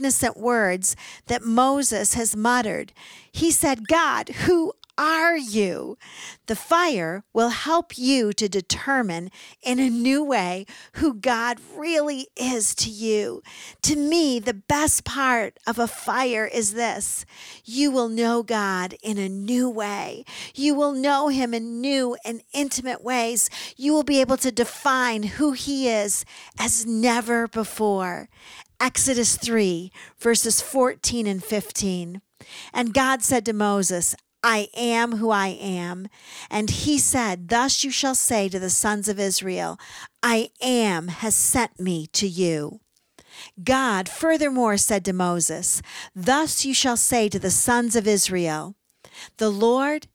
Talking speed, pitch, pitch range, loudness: 140 wpm, 235 Hz, 205-265 Hz, -22 LUFS